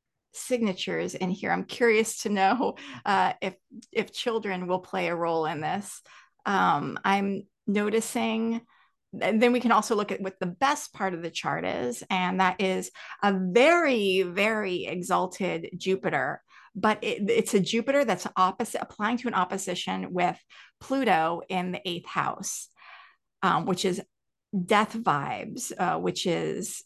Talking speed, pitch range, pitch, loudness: 150 wpm, 185-225 Hz, 195 Hz, -27 LUFS